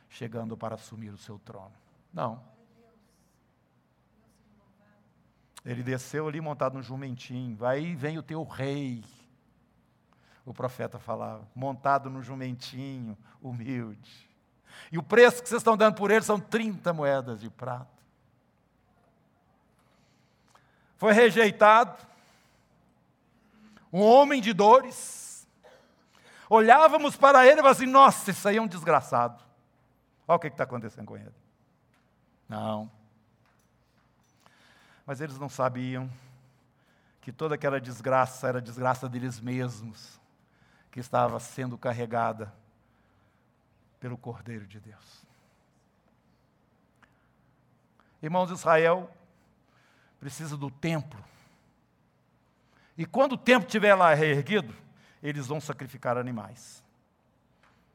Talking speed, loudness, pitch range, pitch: 105 wpm, -25 LUFS, 120-165 Hz, 130 Hz